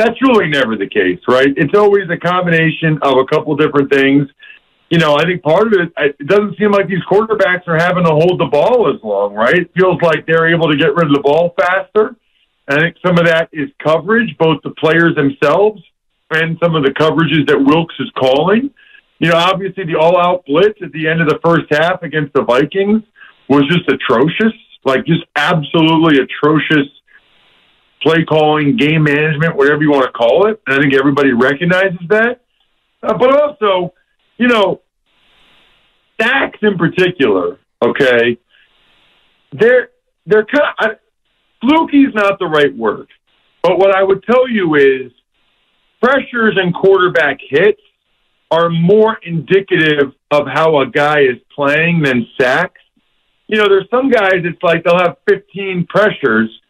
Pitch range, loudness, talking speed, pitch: 150-200 Hz, -12 LUFS, 175 wpm, 170 Hz